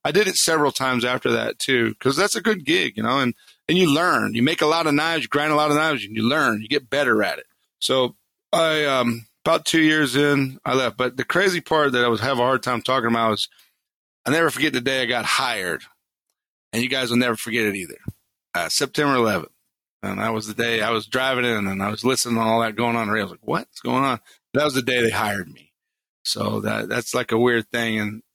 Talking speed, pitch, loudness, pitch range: 260 wpm, 125 Hz, -21 LUFS, 115-145 Hz